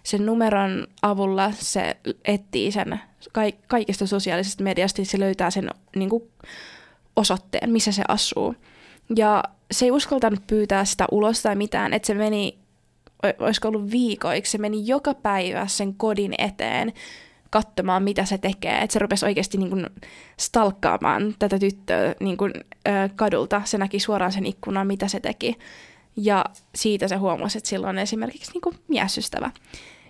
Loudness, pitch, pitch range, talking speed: -23 LUFS, 205 Hz, 195-220 Hz, 150 wpm